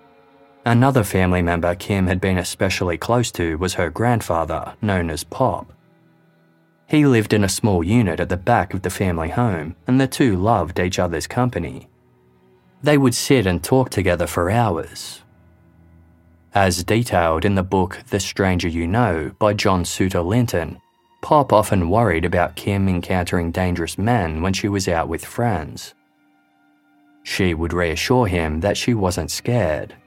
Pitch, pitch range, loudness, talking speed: 95 Hz, 85-110 Hz, -19 LUFS, 155 wpm